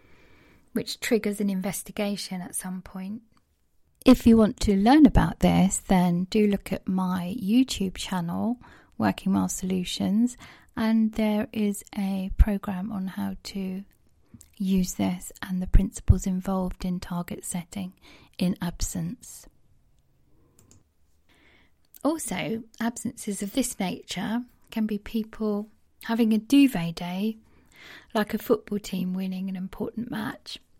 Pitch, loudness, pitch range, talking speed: 200 Hz, -26 LUFS, 185-220 Hz, 125 wpm